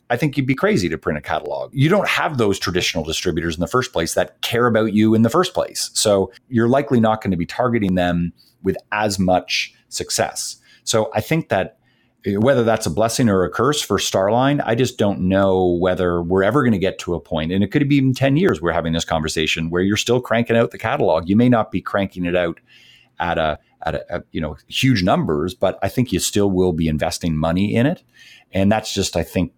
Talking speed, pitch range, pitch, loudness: 235 wpm, 90-120 Hz, 100 Hz, -19 LUFS